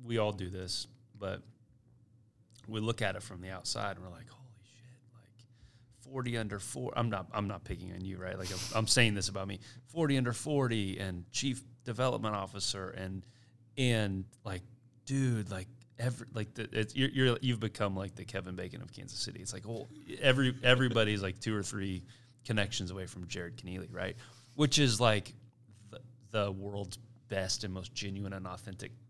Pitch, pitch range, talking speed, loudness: 110 Hz, 95-120 Hz, 190 wpm, -34 LUFS